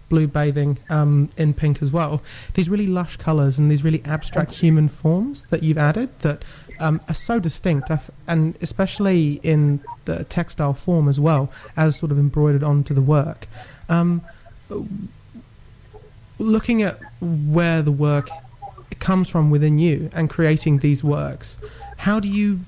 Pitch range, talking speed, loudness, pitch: 145-170 Hz, 150 wpm, -20 LUFS, 155 Hz